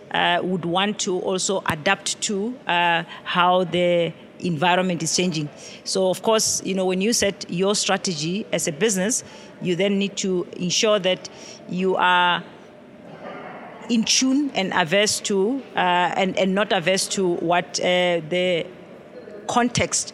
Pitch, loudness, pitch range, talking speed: 190 Hz, -21 LUFS, 180-205 Hz, 145 wpm